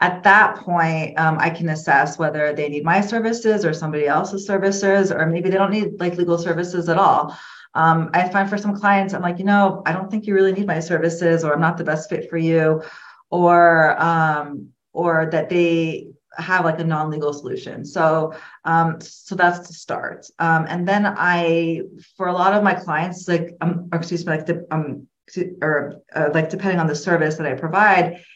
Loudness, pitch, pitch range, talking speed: -19 LUFS, 170 Hz, 160-185 Hz, 205 wpm